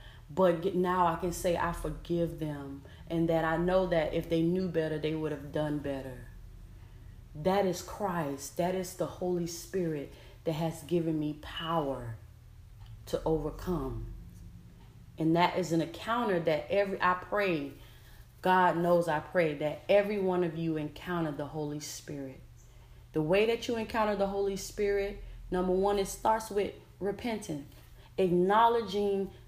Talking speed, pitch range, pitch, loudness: 150 wpm, 145-185 Hz, 165 Hz, -31 LUFS